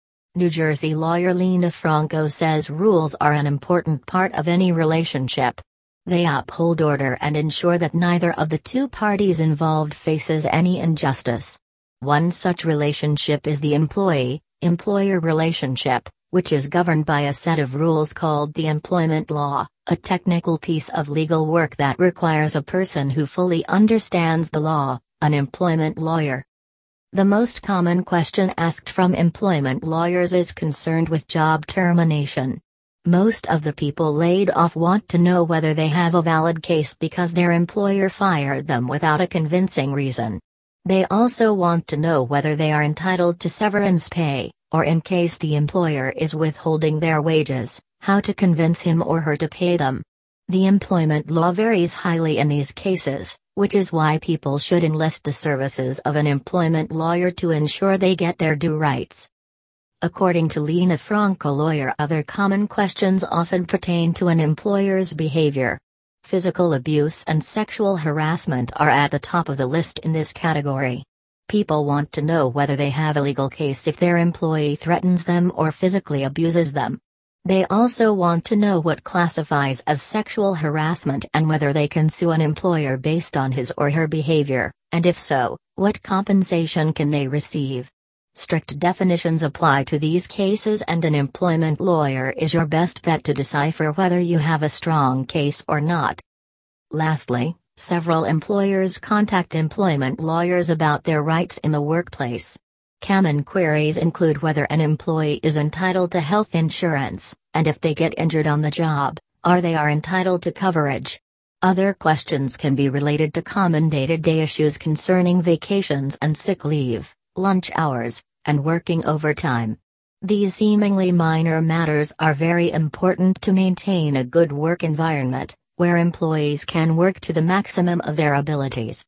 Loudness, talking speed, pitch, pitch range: -20 LUFS, 160 wpm, 160 Hz, 150-175 Hz